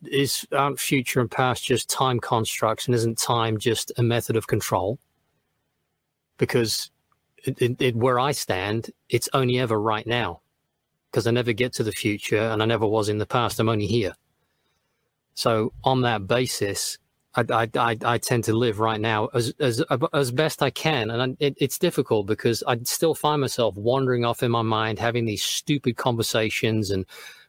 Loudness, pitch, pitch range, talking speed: -24 LUFS, 120 Hz, 110-130 Hz, 185 wpm